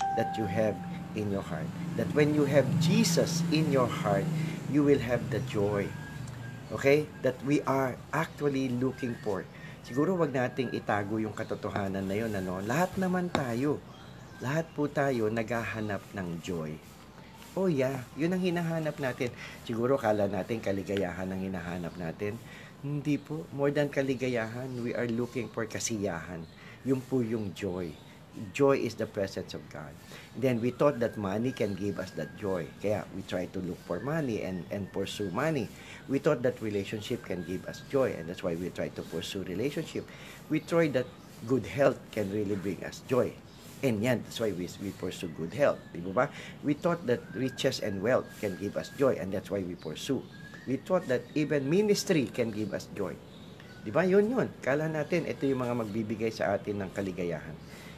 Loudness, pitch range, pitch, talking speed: -31 LUFS, 100-145 Hz, 125 Hz, 180 wpm